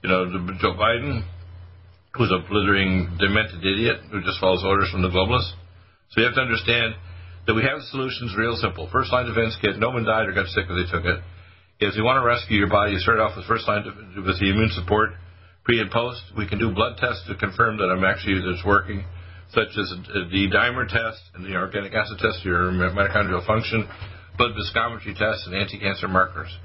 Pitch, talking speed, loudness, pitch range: 100 Hz, 215 wpm, -22 LUFS, 90-110 Hz